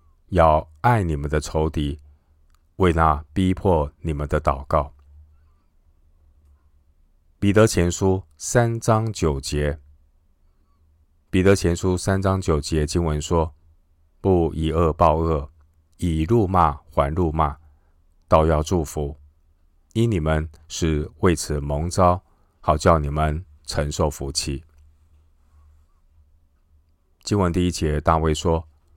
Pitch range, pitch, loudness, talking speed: 75-85 Hz, 80 Hz, -22 LUFS, 155 characters per minute